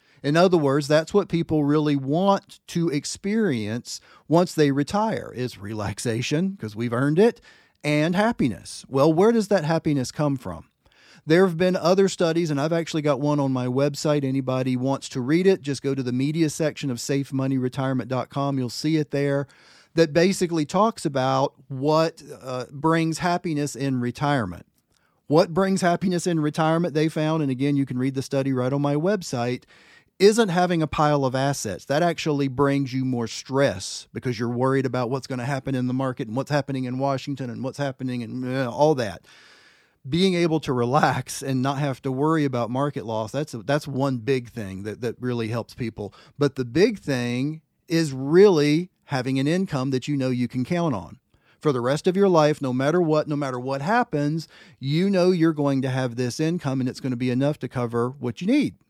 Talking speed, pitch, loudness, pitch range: 195 wpm, 140 Hz, -23 LUFS, 130-160 Hz